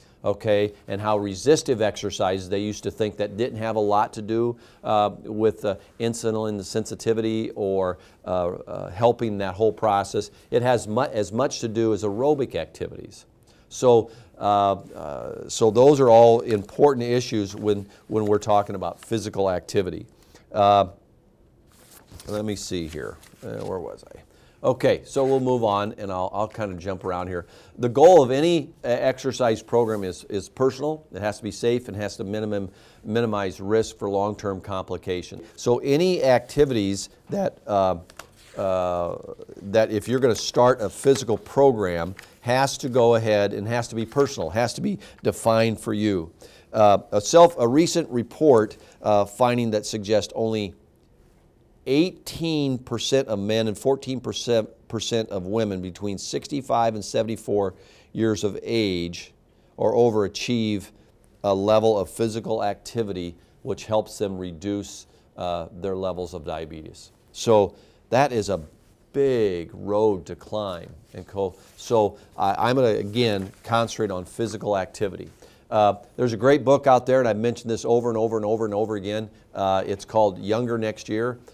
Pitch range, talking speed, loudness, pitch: 100-120 Hz, 155 wpm, -23 LUFS, 110 Hz